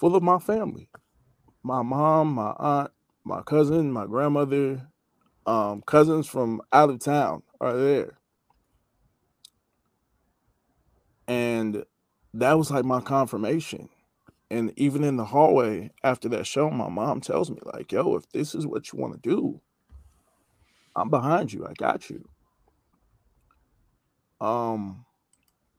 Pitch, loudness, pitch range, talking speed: 135 Hz, -25 LUFS, 115-150 Hz, 125 wpm